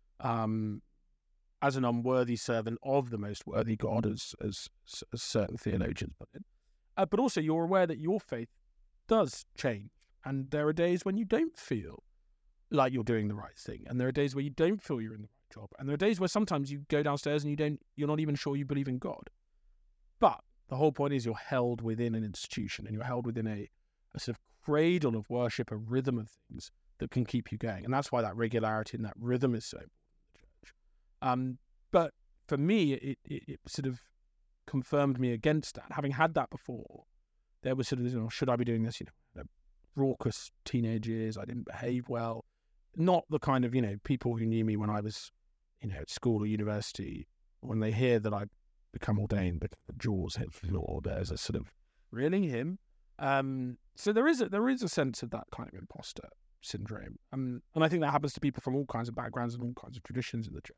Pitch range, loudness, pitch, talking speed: 115-145 Hz, -33 LUFS, 125 Hz, 220 wpm